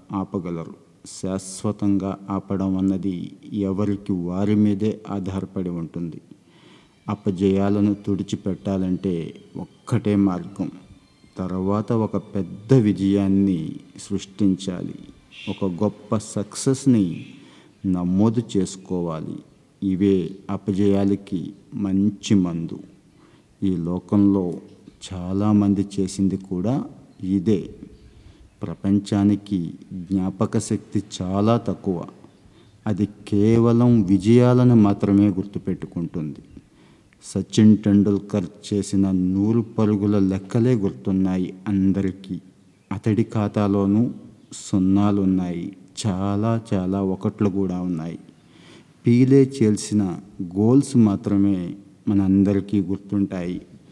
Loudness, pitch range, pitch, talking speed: -22 LUFS, 95-105 Hz, 100 Hz, 75 wpm